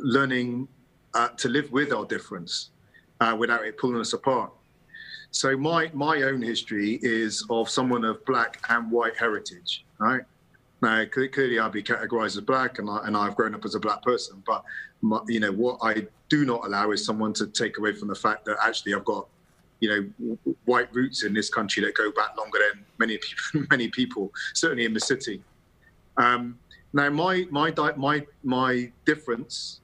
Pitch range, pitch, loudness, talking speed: 110-135 Hz, 120 Hz, -26 LUFS, 190 wpm